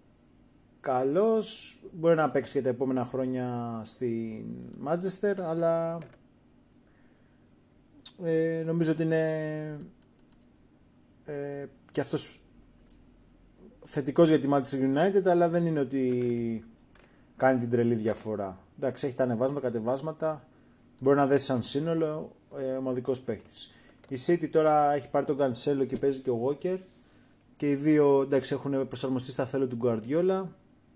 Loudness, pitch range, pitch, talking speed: -27 LUFS, 125-160 Hz, 140 Hz, 130 wpm